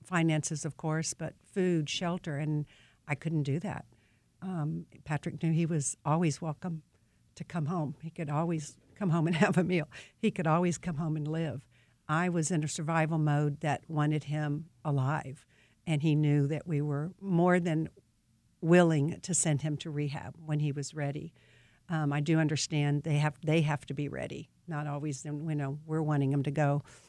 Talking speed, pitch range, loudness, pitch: 190 wpm, 145-165 Hz, -32 LUFS, 155 Hz